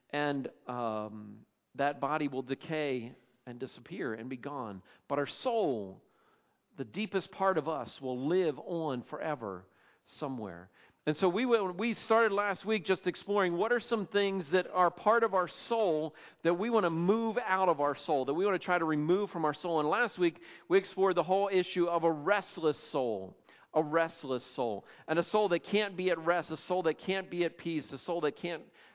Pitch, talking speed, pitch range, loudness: 170 Hz, 200 wpm, 145-195 Hz, -32 LUFS